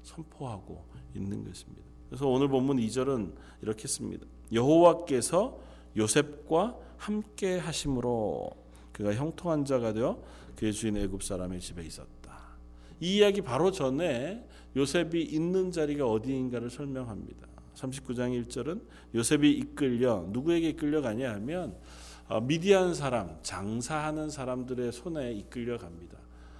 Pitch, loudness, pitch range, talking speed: 125 Hz, -30 LUFS, 90-150 Hz, 290 characters per minute